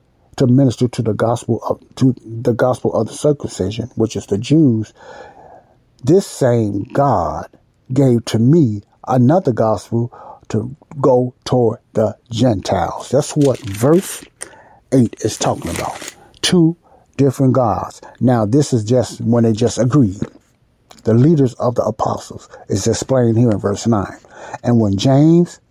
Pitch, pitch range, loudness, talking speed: 120 Hz, 110-135 Hz, -16 LUFS, 140 wpm